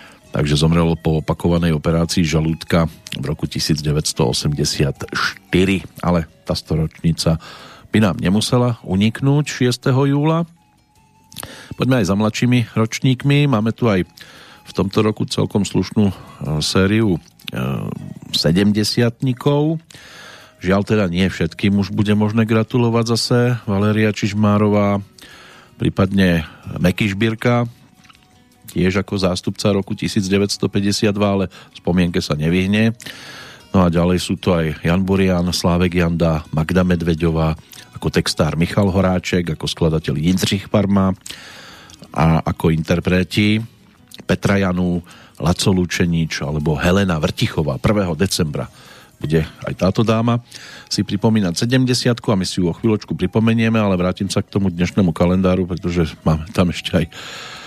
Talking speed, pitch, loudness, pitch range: 120 wpm, 95 Hz, -18 LUFS, 85-110 Hz